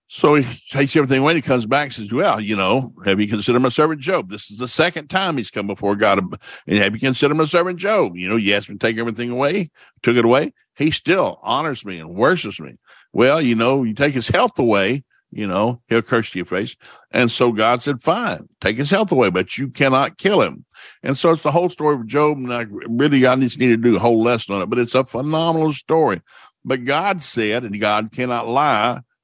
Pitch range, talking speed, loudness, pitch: 115-150 Hz, 240 wpm, -18 LUFS, 125 Hz